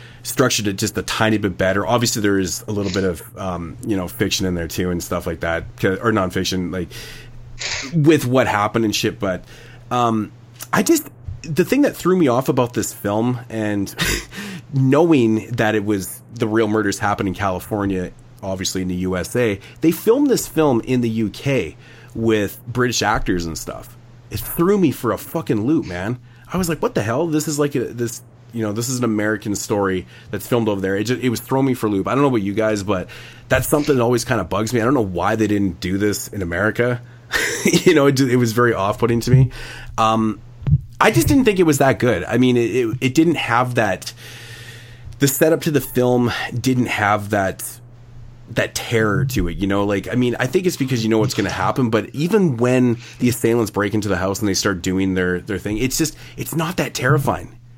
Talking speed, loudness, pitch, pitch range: 220 wpm, -19 LUFS, 115 Hz, 105-125 Hz